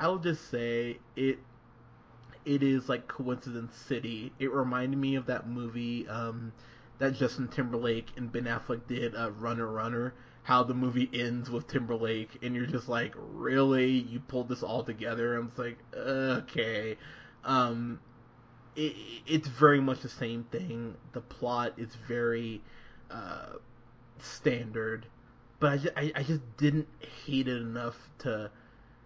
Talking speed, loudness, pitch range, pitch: 145 wpm, -32 LUFS, 115-130 Hz, 120 Hz